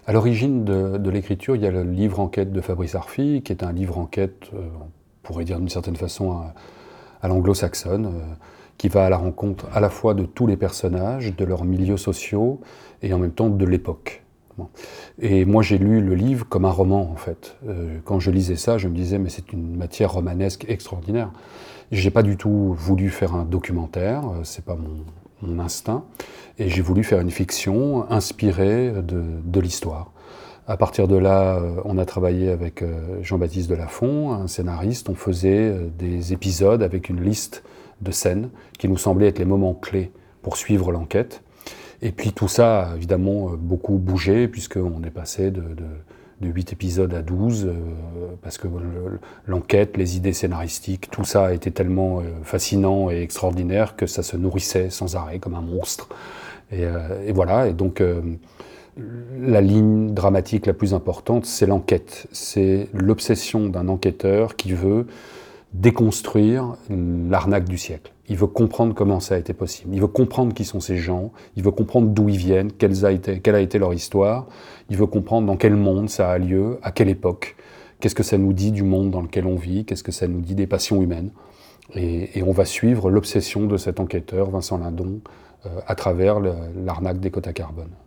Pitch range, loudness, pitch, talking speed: 90-105 Hz, -21 LUFS, 95 Hz, 185 wpm